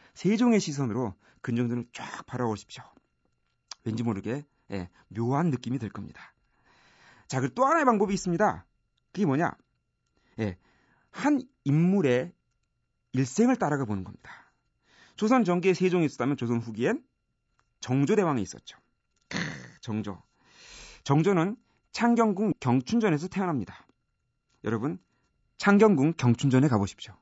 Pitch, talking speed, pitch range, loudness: 140 Hz, 275 characters per minute, 115-190 Hz, -27 LUFS